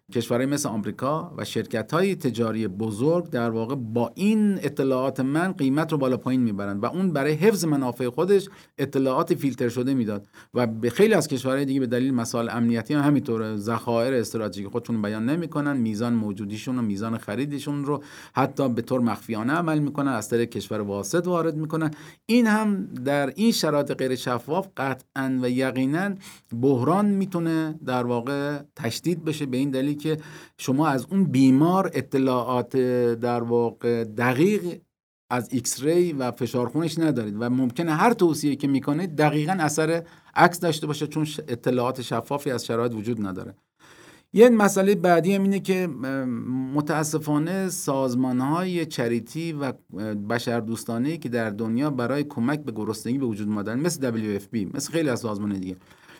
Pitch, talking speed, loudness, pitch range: 135 Hz, 155 wpm, -24 LUFS, 120-155 Hz